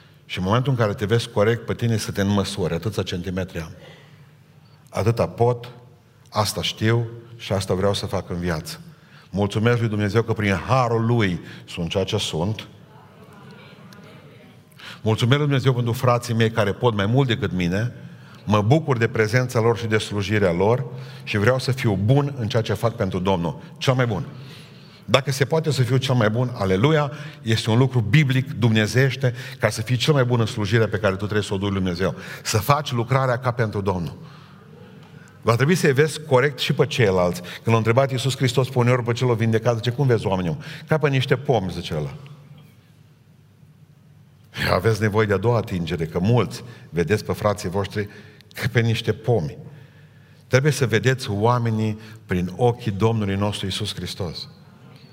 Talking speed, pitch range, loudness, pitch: 175 wpm, 105-135 Hz, -22 LUFS, 120 Hz